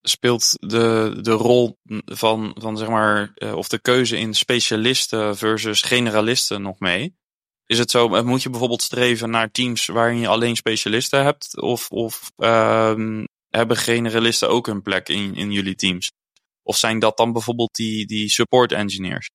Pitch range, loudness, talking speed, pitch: 105-120 Hz, -19 LUFS, 160 wpm, 115 Hz